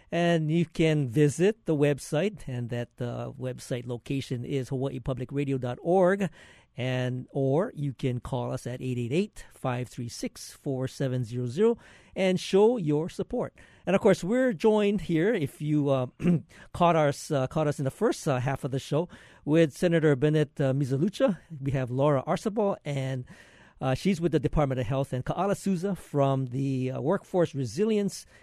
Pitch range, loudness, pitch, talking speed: 130-175 Hz, -28 LUFS, 145 Hz, 155 wpm